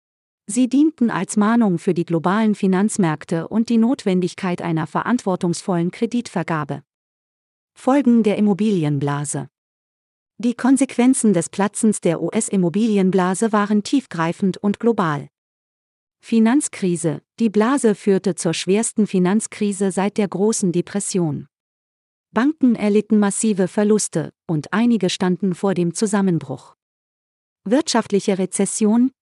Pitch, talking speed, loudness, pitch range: 200 Hz, 105 wpm, -19 LUFS, 175-225 Hz